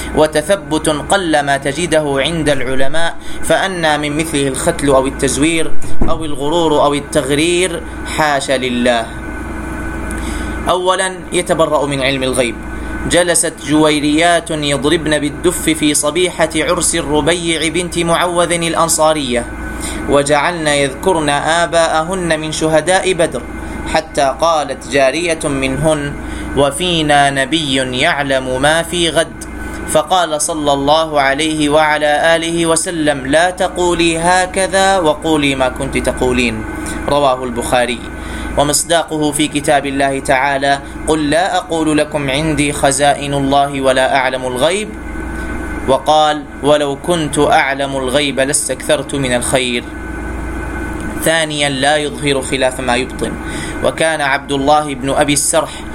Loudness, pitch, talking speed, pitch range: -14 LUFS, 150 Hz, 110 wpm, 140-165 Hz